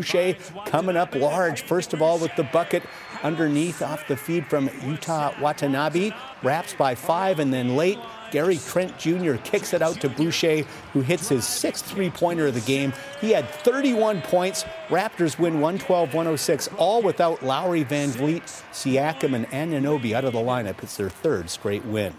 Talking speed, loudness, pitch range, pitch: 170 wpm, -24 LUFS, 140-180 Hz, 160 Hz